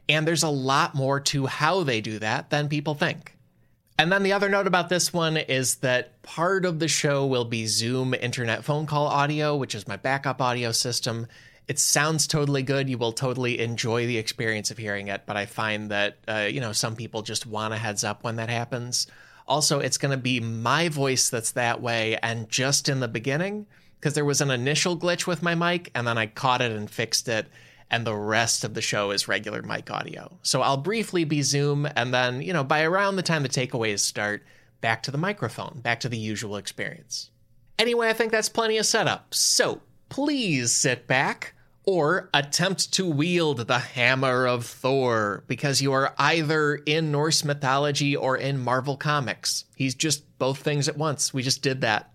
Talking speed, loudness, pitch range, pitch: 205 wpm, -24 LUFS, 115-150 Hz, 135 Hz